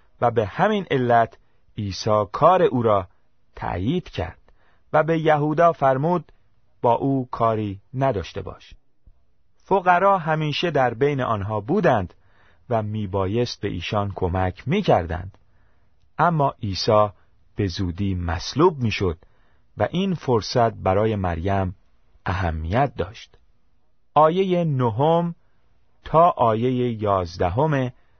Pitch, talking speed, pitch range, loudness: 110 Hz, 105 wpm, 95-140 Hz, -22 LUFS